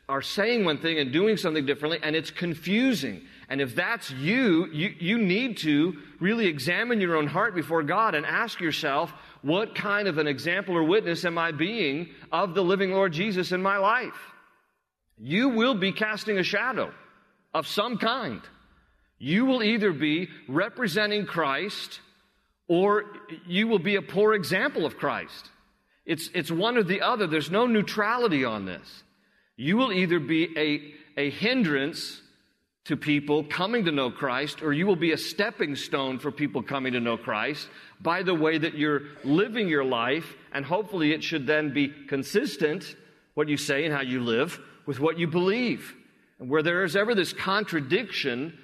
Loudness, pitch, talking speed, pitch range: -26 LUFS, 170 Hz, 175 wpm, 150-205 Hz